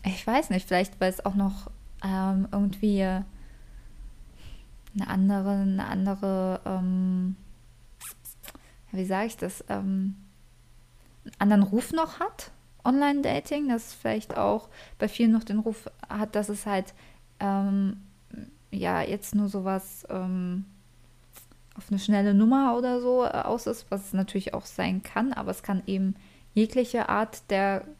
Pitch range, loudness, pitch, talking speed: 190-215 Hz, -28 LUFS, 195 Hz, 140 wpm